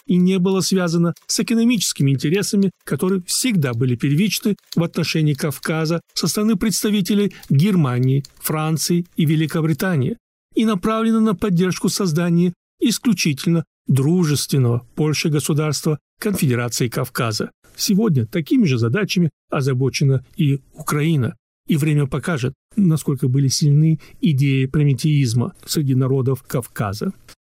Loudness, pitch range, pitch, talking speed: -19 LUFS, 140-190 Hz, 160 Hz, 110 wpm